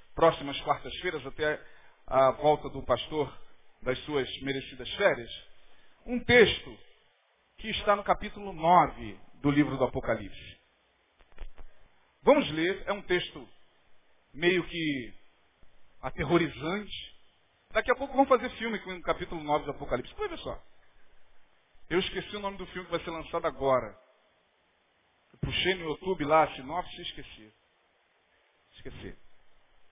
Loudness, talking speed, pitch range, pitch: -29 LUFS, 125 wpm, 130-180 Hz, 155 Hz